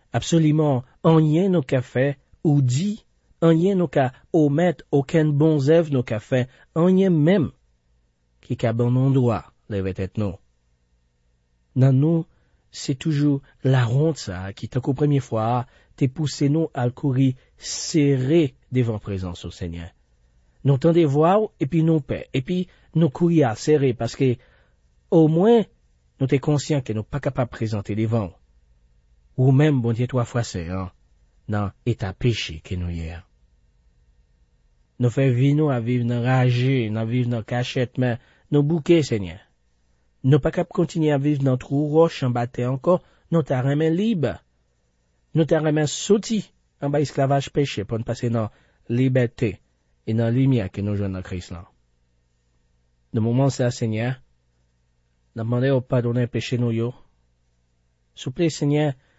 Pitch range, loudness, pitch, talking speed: 90-145 Hz, -22 LUFS, 125 Hz, 155 wpm